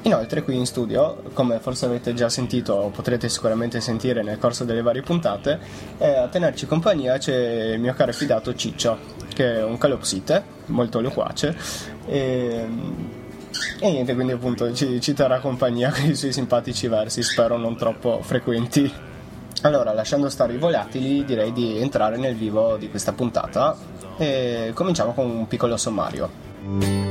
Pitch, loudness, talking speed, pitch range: 120 Hz, -23 LUFS, 155 wpm, 115-130 Hz